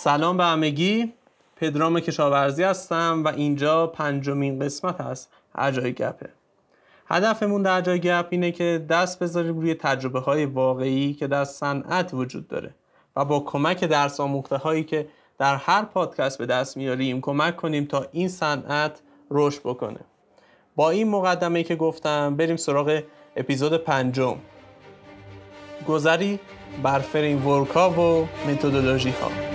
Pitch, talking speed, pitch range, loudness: 150 Hz, 135 wpm, 140-170 Hz, -23 LUFS